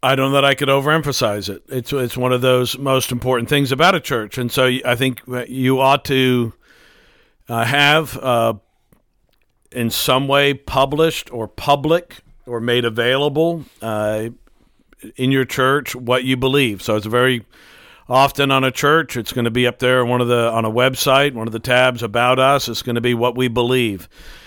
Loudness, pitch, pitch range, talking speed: -17 LUFS, 125 Hz, 120-135 Hz, 190 wpm